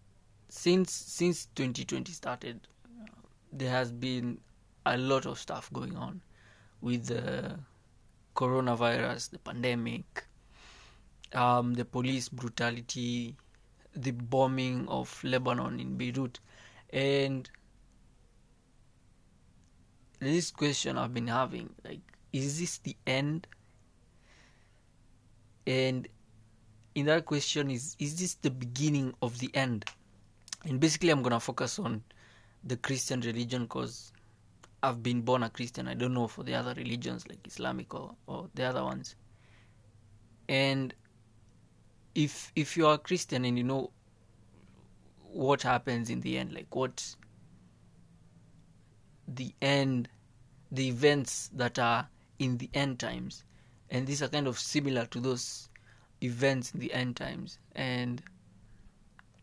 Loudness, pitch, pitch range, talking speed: -33 LUFS, 120 Hz, 110-135 Hz, 125 wpm